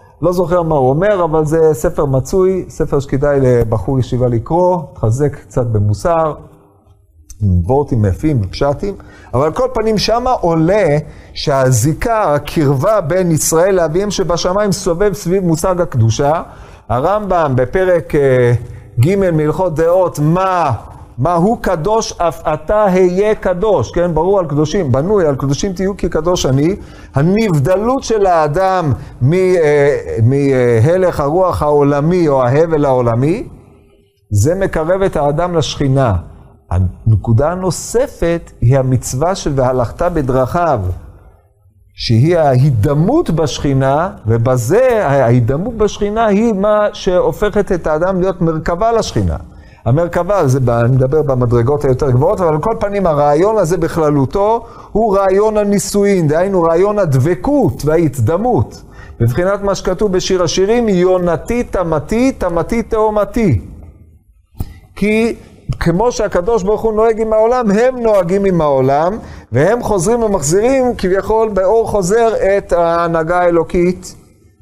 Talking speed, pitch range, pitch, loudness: 115 wpm, 130-195 Hz, 165 Hz, -13 LUFS